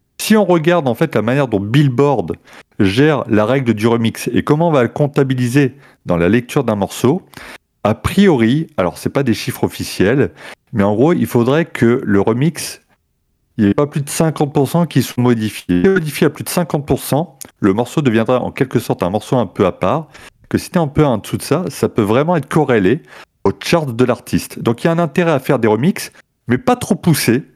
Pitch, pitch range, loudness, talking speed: 135 Hz, 115-155 Hz, -15 LUFS, 225 wpm